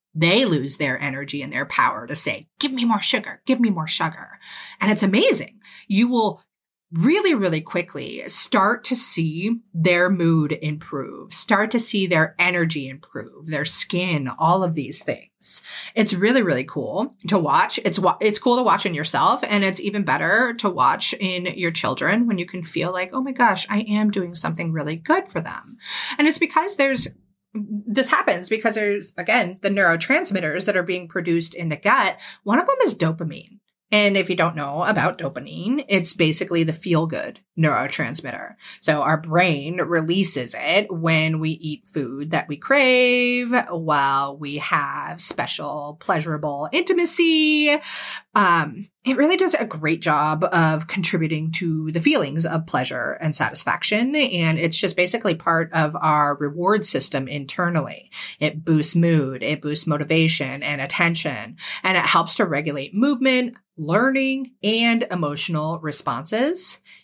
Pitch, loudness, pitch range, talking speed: 175 Hz, -20 LUFS, 155-215 Hz, 160 wpm